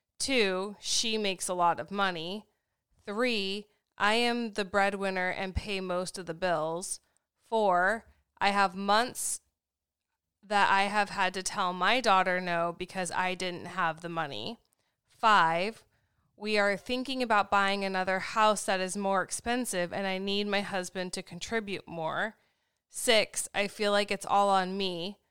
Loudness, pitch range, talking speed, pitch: -29 LUFS, 180-205 Hz, 155 wpm, 195 Hz